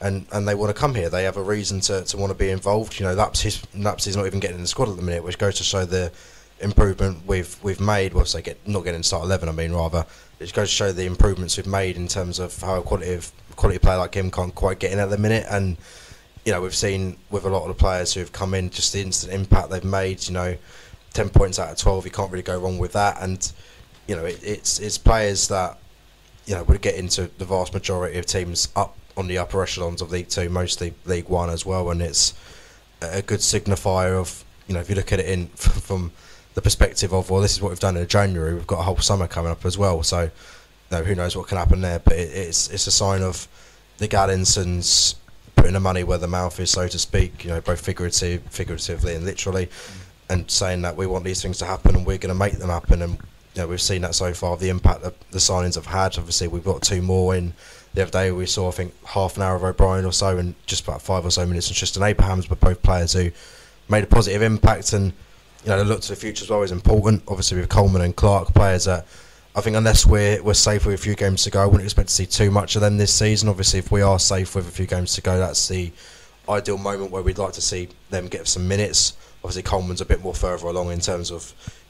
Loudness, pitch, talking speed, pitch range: -21 LUFS, 95 Hz, 260 wpm, 90-100 Hz